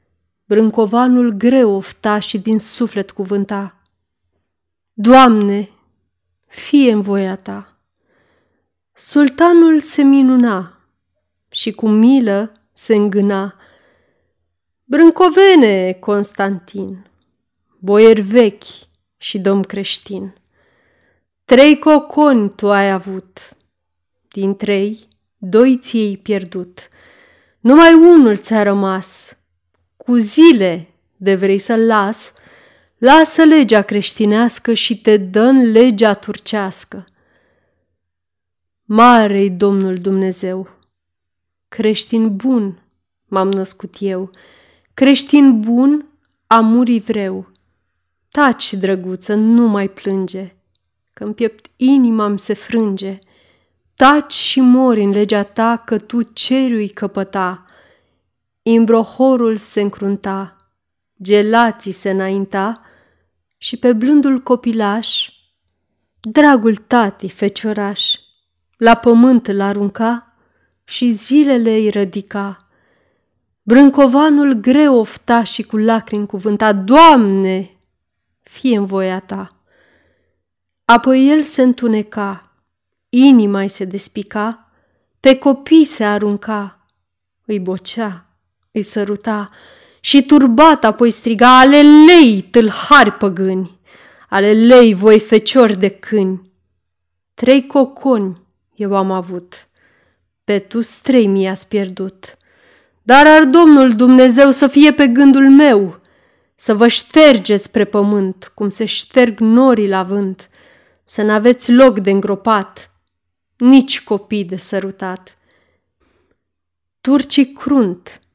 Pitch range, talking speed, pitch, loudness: 190-245 Hz, 100 wpm, 210 Hz, -12 LUFS